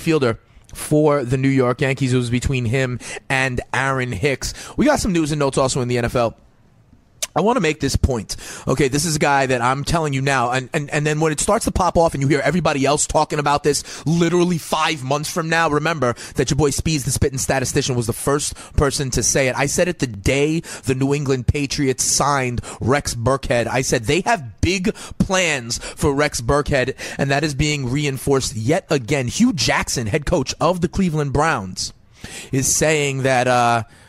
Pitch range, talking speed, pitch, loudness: 125-155 Hz, 205 wpm, 140 Hz, -19 LUFS